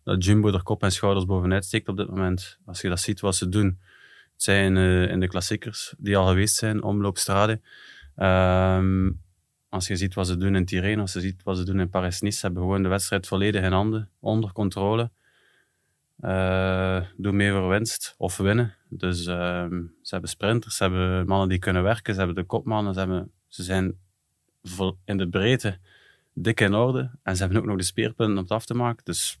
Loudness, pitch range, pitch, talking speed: -24 LUFS, 95-105 Hz, 95 Hz, 205 wpm